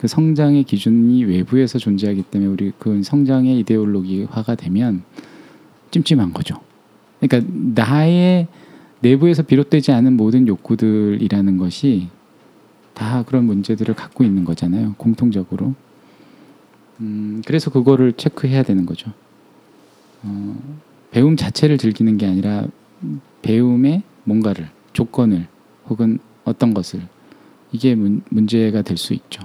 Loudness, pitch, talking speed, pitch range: -17 LUFS, 115 Hz, 280 characters per minute, 100-135 Hz